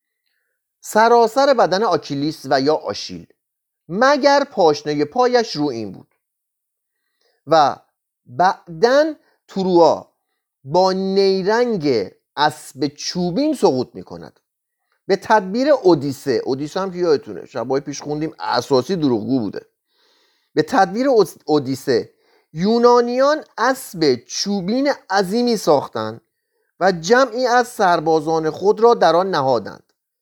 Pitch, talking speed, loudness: 200 Hz, 105 wpm, -18 LUFS